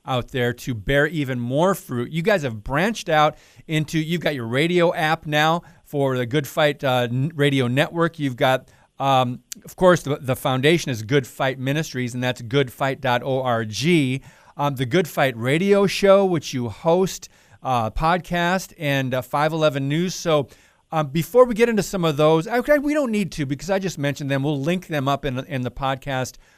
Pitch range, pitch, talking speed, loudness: 130-165 Hz, 145 Hz, 185 wpm, -21 LUFS